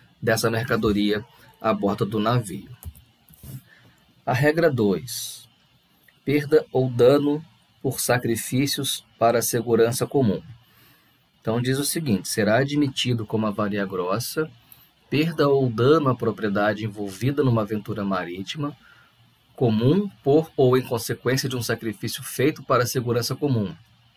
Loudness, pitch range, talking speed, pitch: -23 LUFS, 110-140 Hz, 120 wpm, 120 Hz